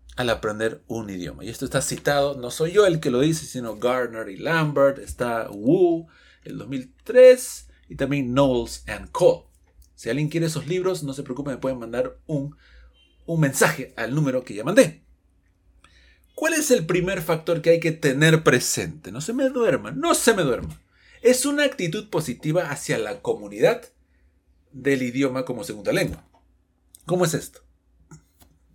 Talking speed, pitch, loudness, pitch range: 165 wpm, 140 Hz, -22 LUFS, 115-165 Hz